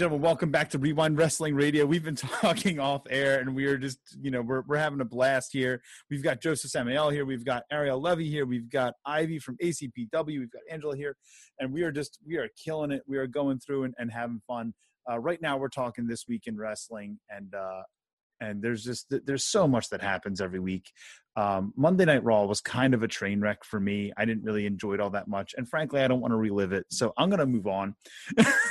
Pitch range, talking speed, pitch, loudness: 110-150 Hz, 235 wpm, 130 Hz, -29 LUFS